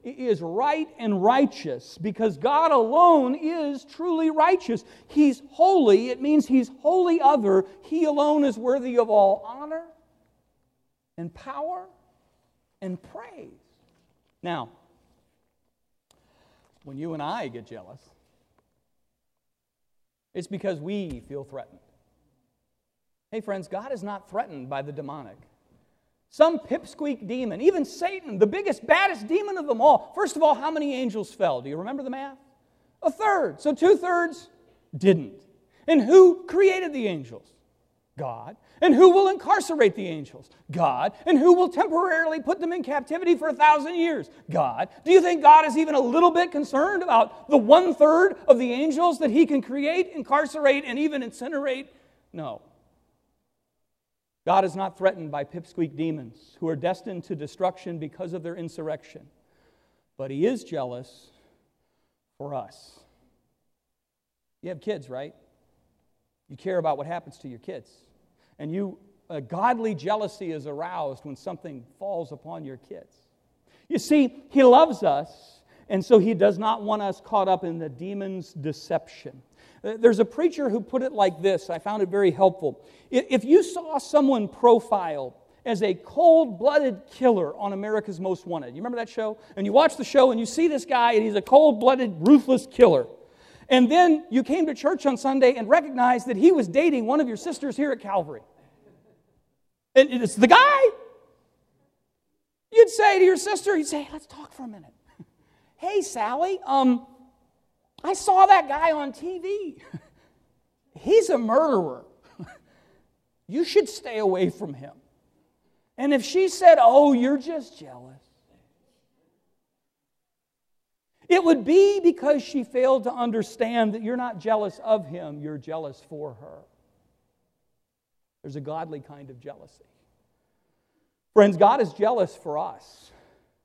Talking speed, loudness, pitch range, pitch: 150 wpm, -22 LUFS, 190-315 Hz, 255 Hz